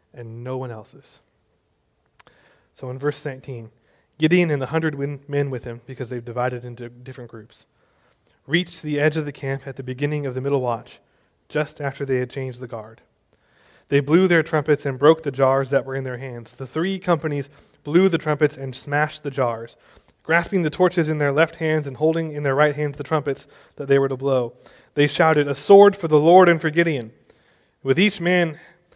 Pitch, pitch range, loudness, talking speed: 140 Hz, 130-155 Hz, -21 LUFS, 200 wpm